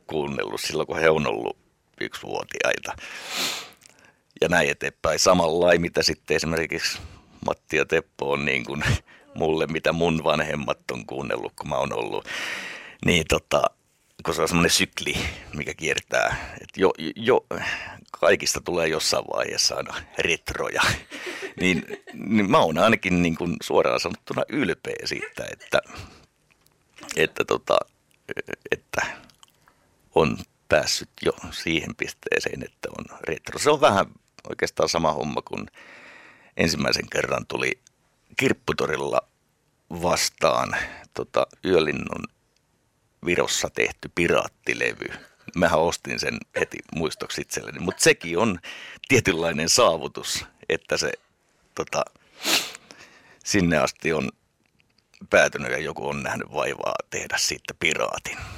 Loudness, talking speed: -24 LUFS, 120 wpm